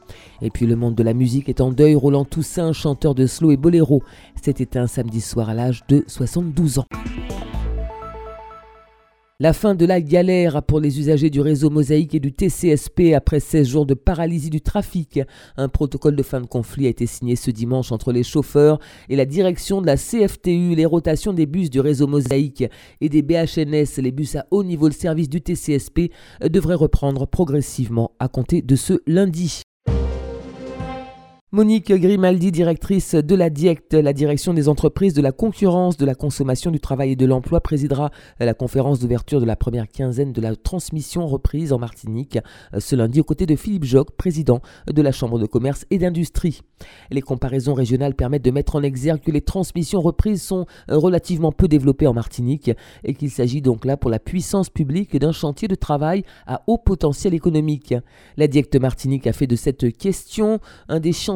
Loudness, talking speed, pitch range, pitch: -19 LUFS, 185 wpm, 130-170 Hz, 145 Hz